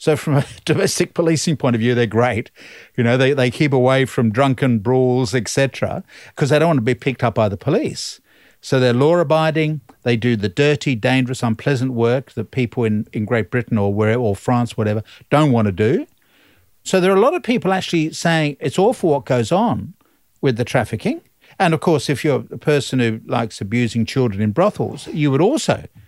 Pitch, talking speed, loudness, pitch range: 130 Hz, 205 wpm, -18 LUFS, 120-150 Hz